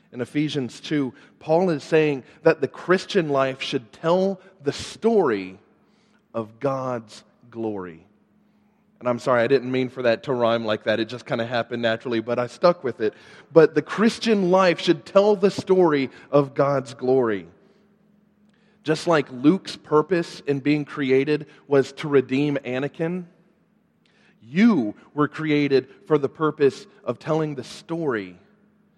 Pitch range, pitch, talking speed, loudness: 130-190 Hz, 150 Hz, 150 wpm, -22 LUFS